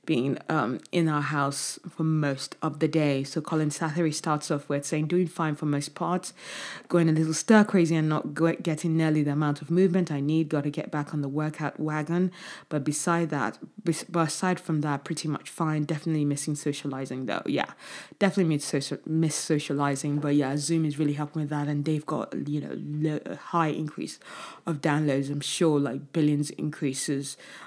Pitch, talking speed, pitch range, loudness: 155 Hz, 190 wpm, 145-165 Hz, -27 LUFS